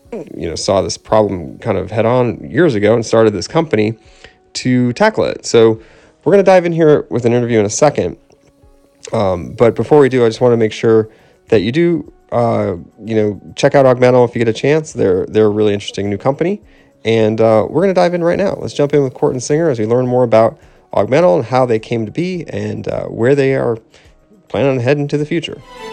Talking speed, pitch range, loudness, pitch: 235 wpm, 110-145 Hz, -14 LUFS, 120 Hz